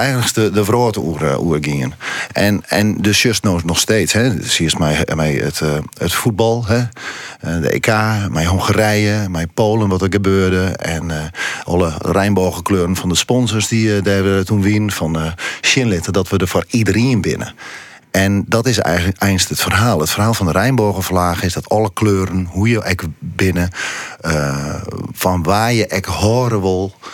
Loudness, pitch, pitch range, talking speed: -16 LUFS, 95 Hz, 85-110 Hz, 180 wpm